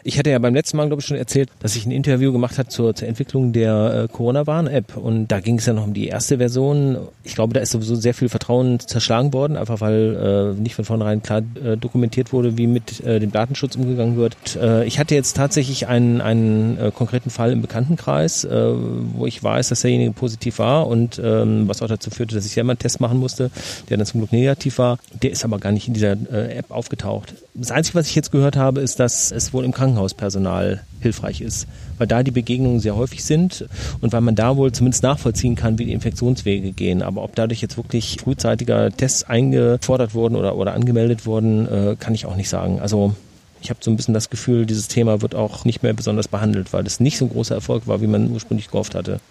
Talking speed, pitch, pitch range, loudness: 230 wpm, 115 Hz, 110-125 Hz, -19 LUFS